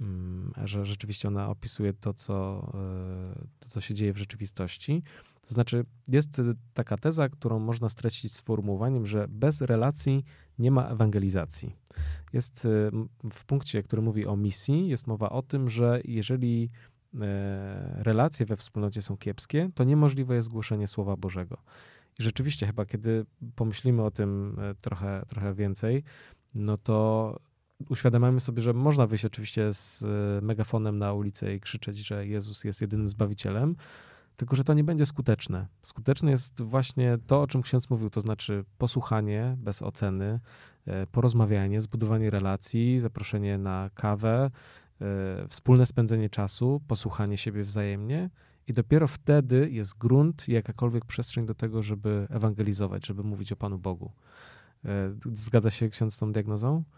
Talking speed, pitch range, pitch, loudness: 140 wpm, 105-125 Hz, 110 Hz, -29 LUFS